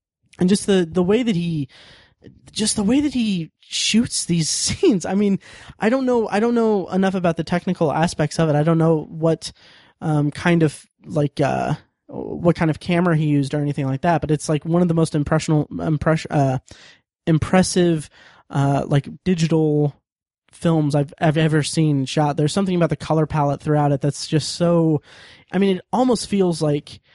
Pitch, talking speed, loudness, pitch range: 160 Hz, 190 wpm, -20 LUFS, 150-180 Hz